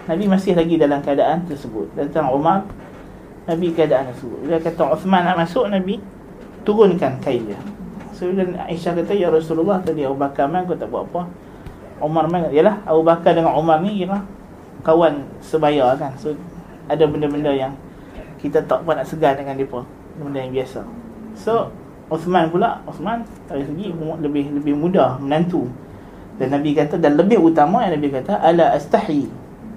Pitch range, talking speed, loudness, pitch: 145-180 Hz, 165 wpm, -19 LUFS, 160 Hz